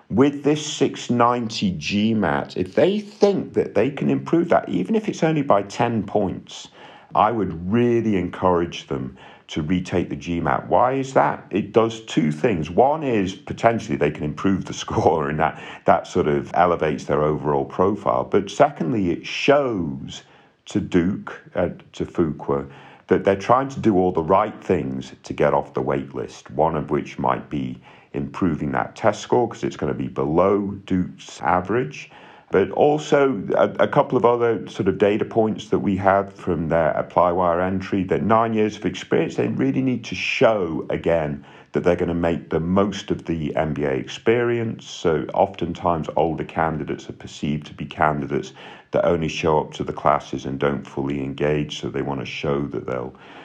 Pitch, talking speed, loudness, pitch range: 90 Hz, 180 wpm, -21 LUFS, 75-115 Hz